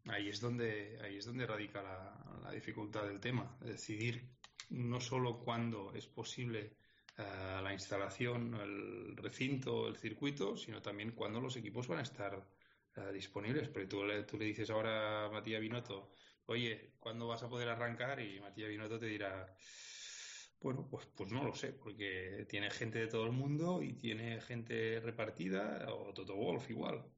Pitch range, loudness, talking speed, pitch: 105-120 Hz, -43 LUFS, 170 wpm, 110 Hz